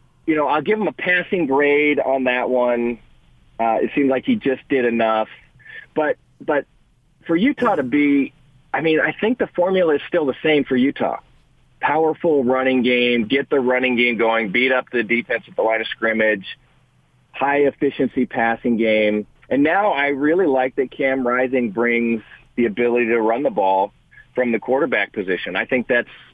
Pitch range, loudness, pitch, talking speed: 120-140 Hz, -19 LUFS, 130 Hz, 180 wpm